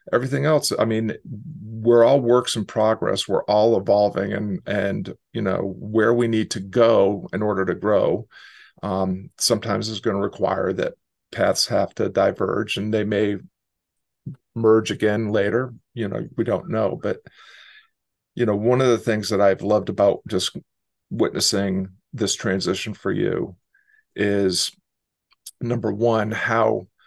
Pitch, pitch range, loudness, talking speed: 110 Hz, 100-120 Hz, -21 LUFS, 150 wpm